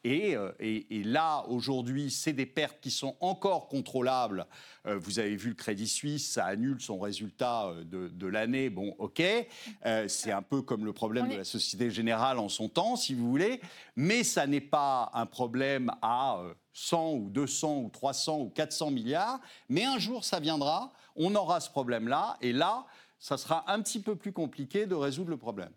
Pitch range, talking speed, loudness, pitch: 115-165 Hz, 190 wpm, -32 LUFS, 135 Hz